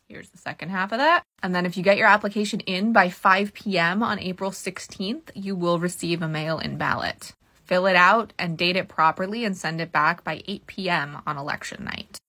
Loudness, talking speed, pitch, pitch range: -23 LUFS, 215 wpm, 190 Hz, 175-205 Hz